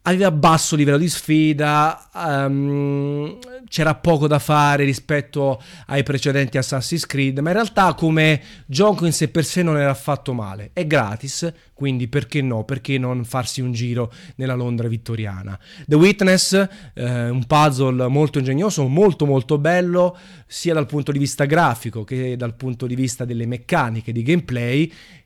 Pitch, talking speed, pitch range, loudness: 145 Hz, 155 wpm, 130-160 Hz, -19 LUFS